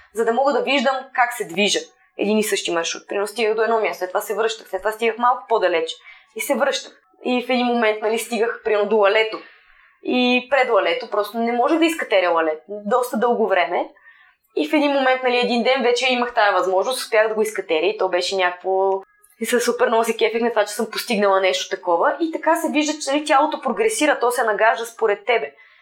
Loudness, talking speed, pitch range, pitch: -20 LUFS, 220 wpm, 205-255 Hz, 230 Hz